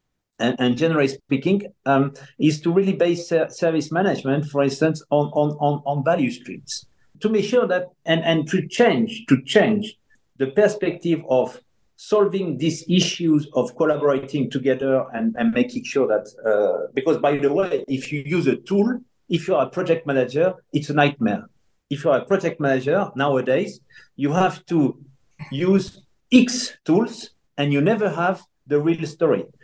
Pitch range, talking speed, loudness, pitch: 140-195 Hz, 165 wpm, -21 LUFS, 165 Hz